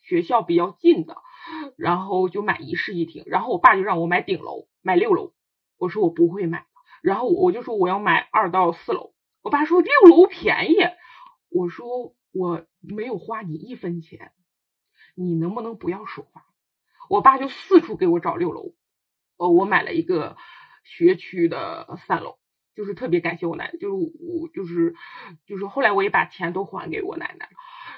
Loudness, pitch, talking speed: -21 LUFS, 325 Hz, 255 characters per minute